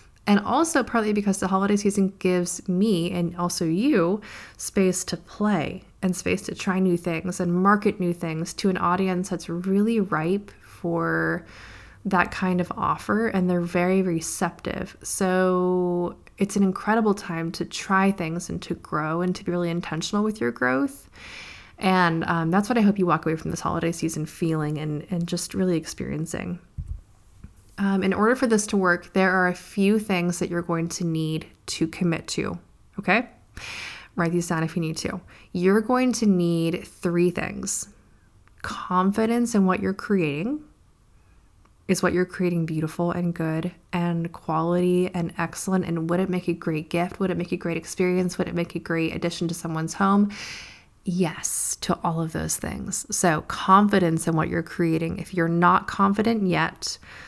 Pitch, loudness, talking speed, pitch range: 175 Hz, -24 LUFS, 175 wpm, 165-190 Hz